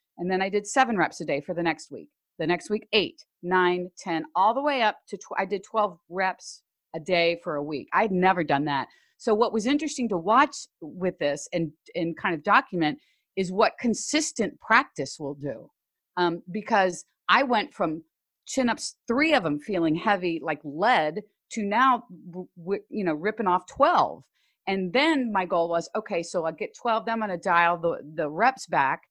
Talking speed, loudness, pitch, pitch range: 200 wpm, -25 LUFS, 190 Hz, 170-225 Hz